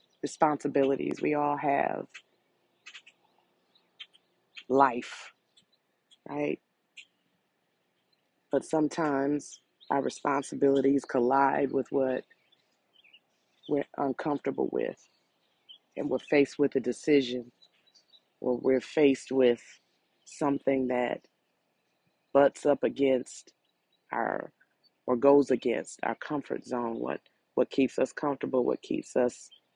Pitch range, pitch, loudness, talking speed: 130-140 Hz, 135 Hz, -29 LUFS, 95 wpm